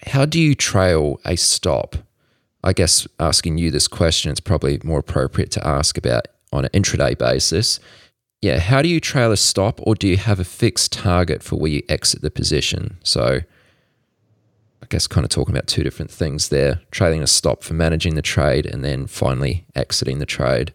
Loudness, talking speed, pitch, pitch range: -18 LUFS, 195 wpm, 85 Hz, 75-105 Hz